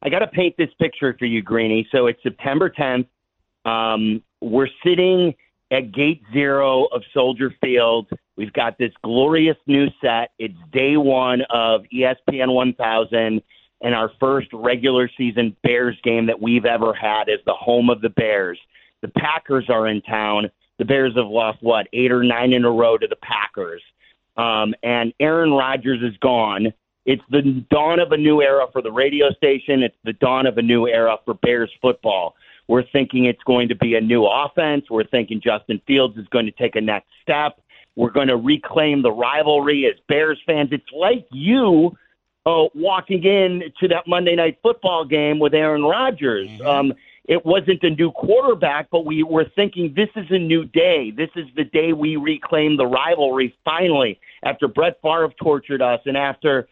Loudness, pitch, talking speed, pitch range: -18 LUFS, 135 Hz, 180 wpm, 120-160 Hz